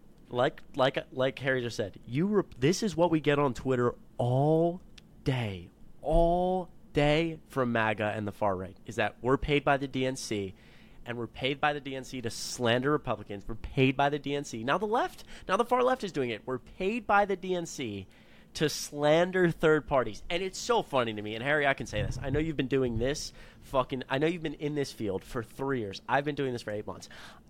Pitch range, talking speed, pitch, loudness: 115-155 Hz, 220 wpm, 135 Hz, -30 LUFS